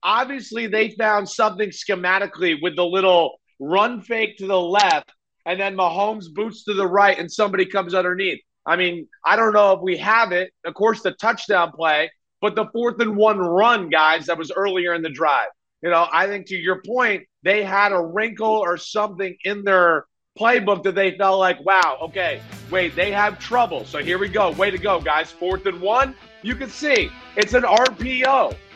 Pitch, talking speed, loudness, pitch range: 200 Hz, 195 wpm, -20 LUFS, 180-220 Hz